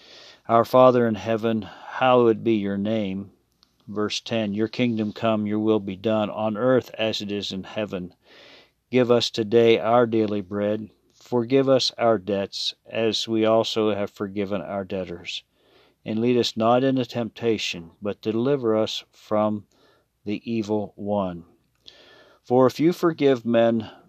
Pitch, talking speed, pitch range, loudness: 110 Hz, 145 wpm, 105-115 Hz, -23 LUFS